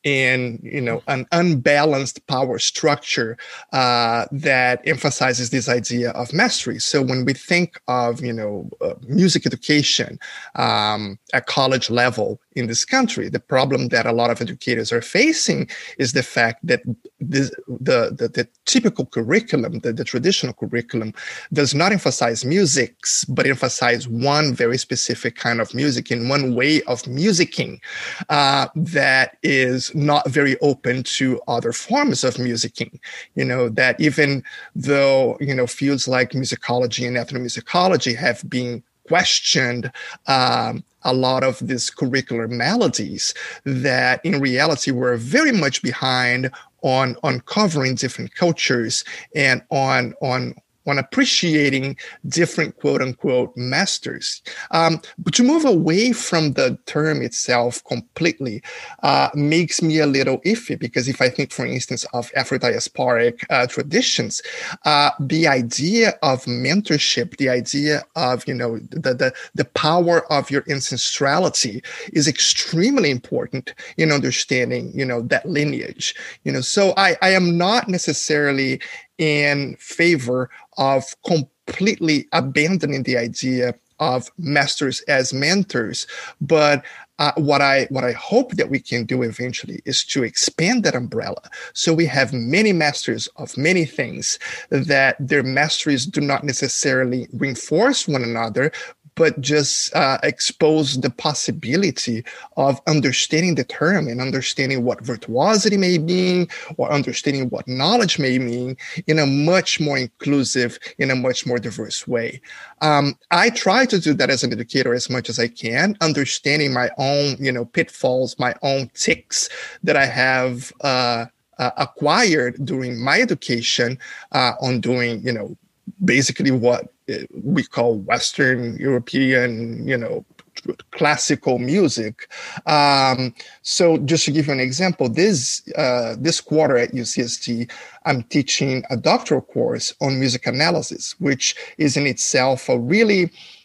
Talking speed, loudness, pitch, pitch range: 140 wpm, -19 LUFS, 135 Hz, 125-155 Hz